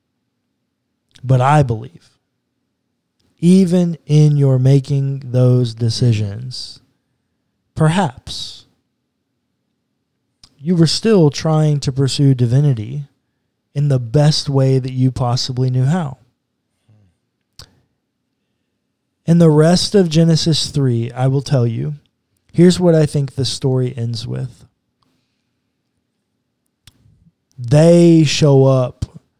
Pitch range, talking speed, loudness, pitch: 125-150 Hz, 95 wpm, -14 LUFS, 135 Hz